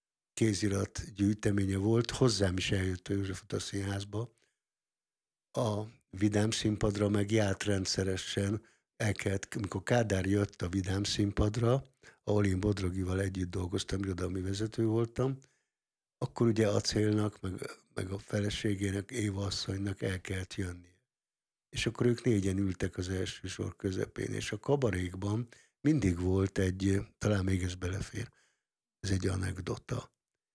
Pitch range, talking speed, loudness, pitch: 95-110 Hz, 130 wpm, -33 LUFS, 100 Hz